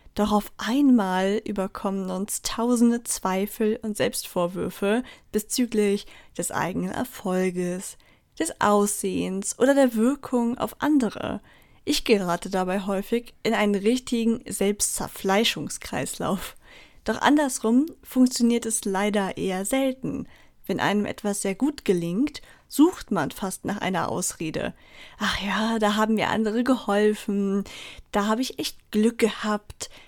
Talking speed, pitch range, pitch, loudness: 120 wpm, 200-240 Hz, 215 Hz, -25 LUFS